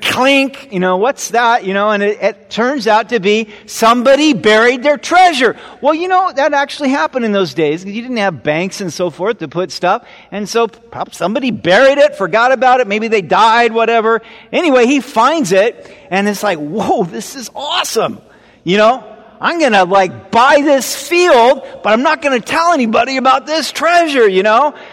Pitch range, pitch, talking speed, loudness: 205-275 Hz, 230 Hz, 195 wpm, -12 LUFS